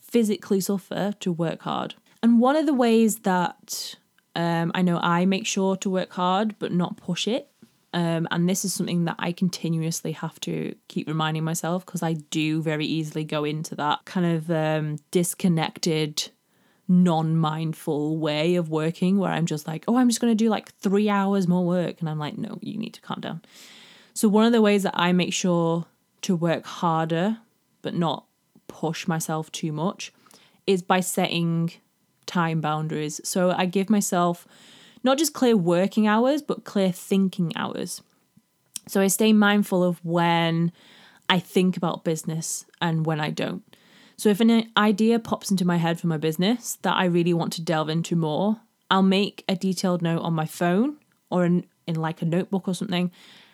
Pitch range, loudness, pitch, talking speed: 165-205 Hz, -24 LUFS, 180 Hz, 185 wpm